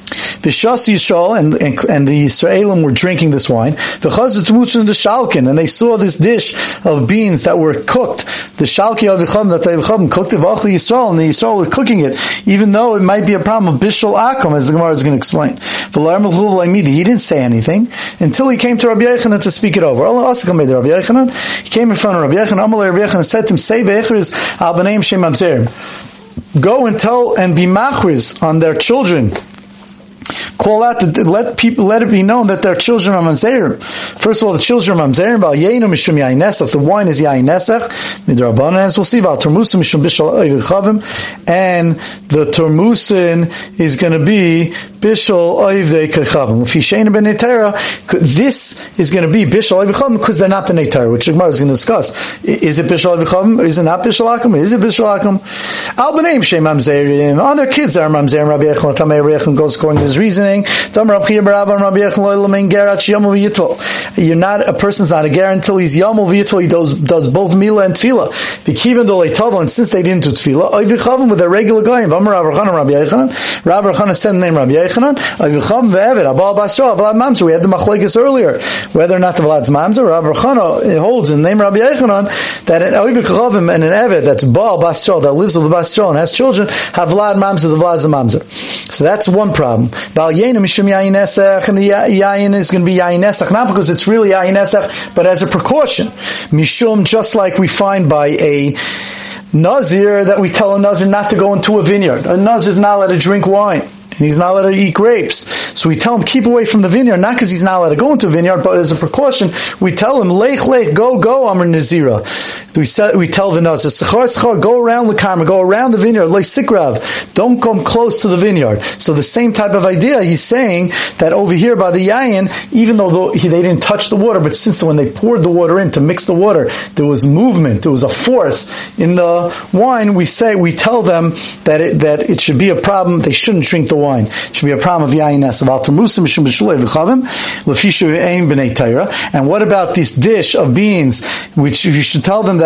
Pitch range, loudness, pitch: 165-215 Hz, -10 LUFS, 195 Hz